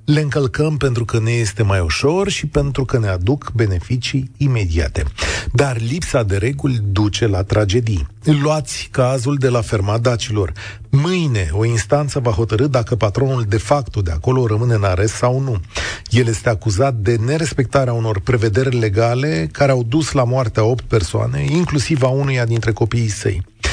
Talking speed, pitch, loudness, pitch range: 165 wpm, 120 Hz, -17 LUFS, 110-140 Hz